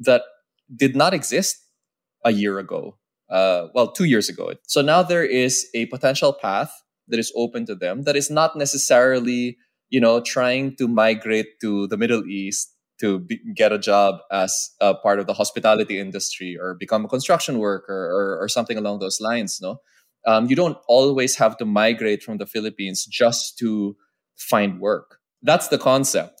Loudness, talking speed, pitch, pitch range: -20 LUFS, 180 wpm, 115 Hz, 105-135 Hz